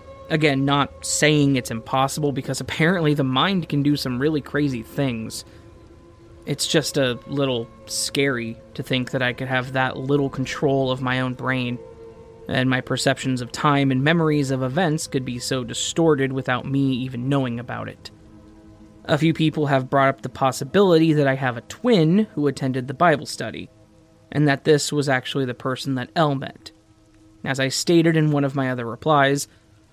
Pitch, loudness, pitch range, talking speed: 135 Hz, -21 LUFS, 120-145 Hz, 180 wpm